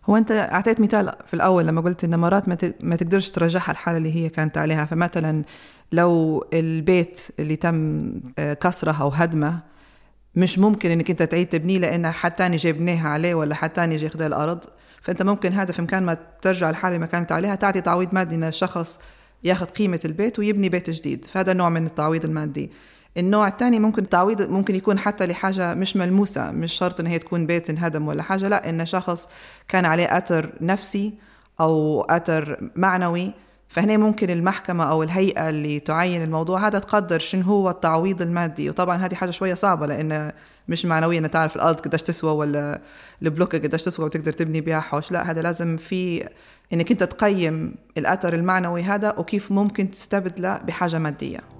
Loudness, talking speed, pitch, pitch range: -22 LUFS, 175 wpm, 175 Hz, 160-190 Hz